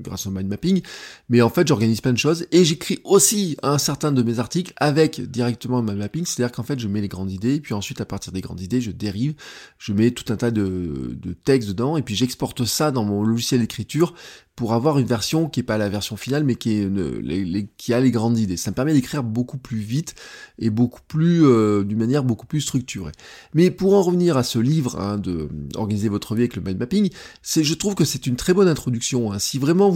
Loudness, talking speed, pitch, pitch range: -21 LUFS, 255 wpm, 120 Hz, 105-150 Hz